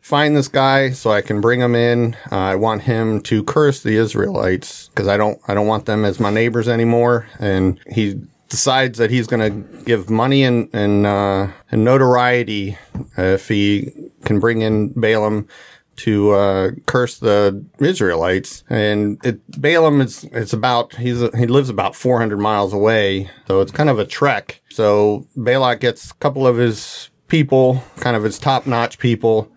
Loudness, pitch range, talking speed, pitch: -17 LUFS, 105-125 Hz, 175 wpm, 115 Hz